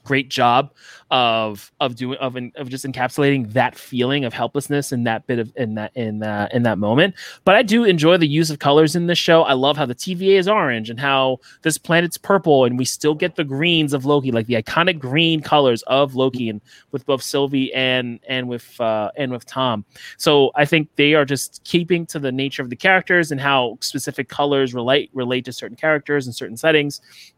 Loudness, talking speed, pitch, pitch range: -18 LUFS, 215 wpm, 140 Hz, 125-155 Hz